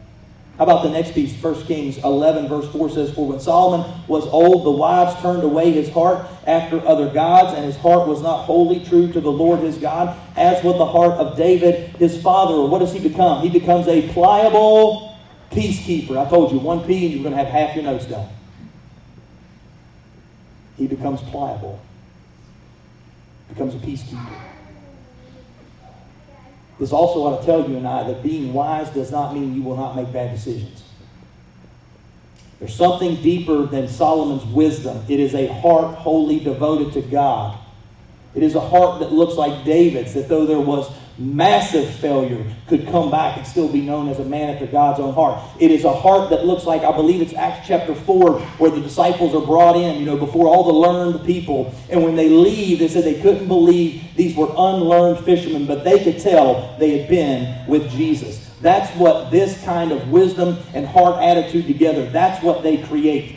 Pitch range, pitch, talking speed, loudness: 140-175 Hz, 155 Hz, 185 wpm, -16 LUFS